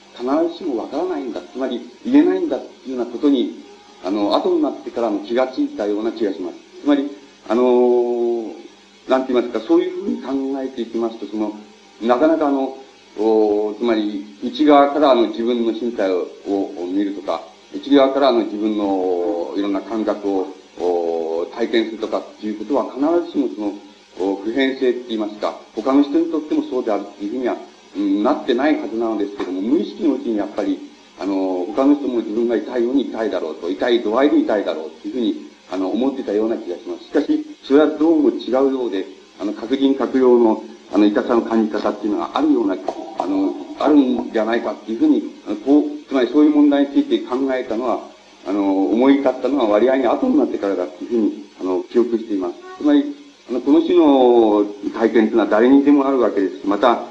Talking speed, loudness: 415 characters per minute, -19 LUFS